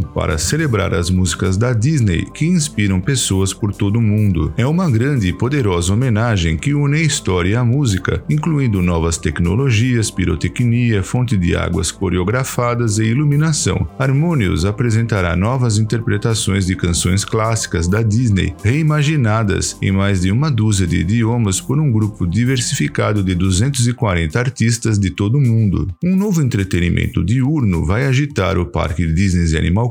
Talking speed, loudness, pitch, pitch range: 145 wpm, -16 LUFS, 105 Hz, 95-125 Hz